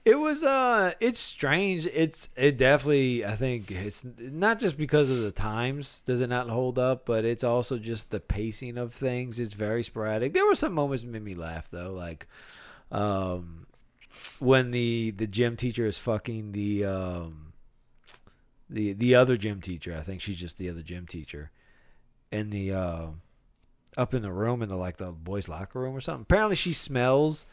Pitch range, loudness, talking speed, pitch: 95-130 Hz, -28 LUFS, 185 wpm, 115 Hz